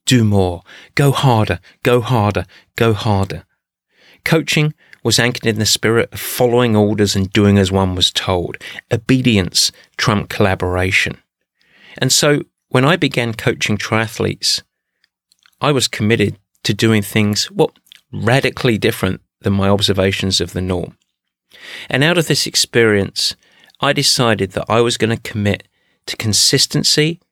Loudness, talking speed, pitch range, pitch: -15 LUFS, 140 wpm, 100-125 Hz, 110 Hz